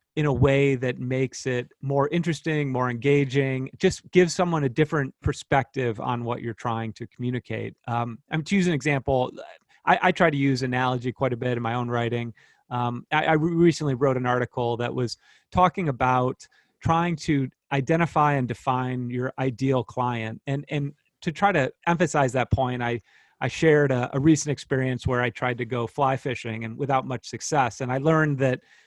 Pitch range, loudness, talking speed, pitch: 125-145 Hz, -25 LUFS, 185 wpm, 130 Hz